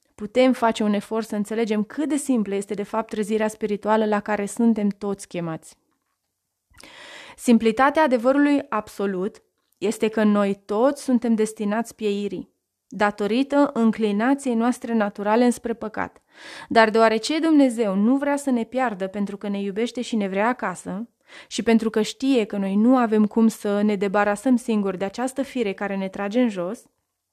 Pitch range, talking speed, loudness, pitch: 205-245 Hz, 160 wpm, -22 LUFS, 220 Hz